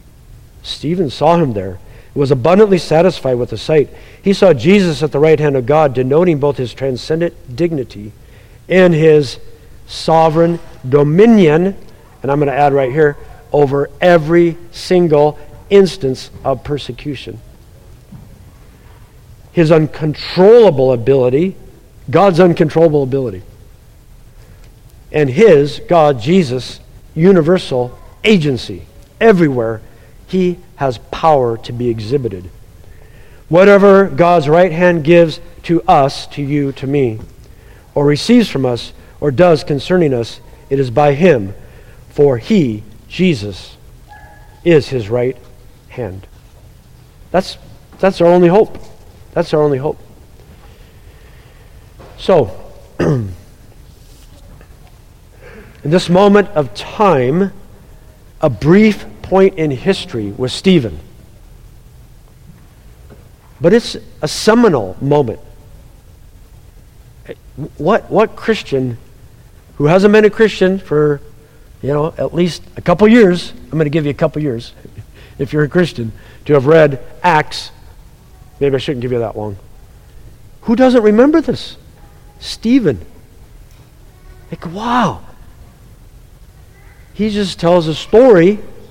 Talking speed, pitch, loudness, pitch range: 115 wpm, 145 Hz, -12 LUFS, 115-170 Hz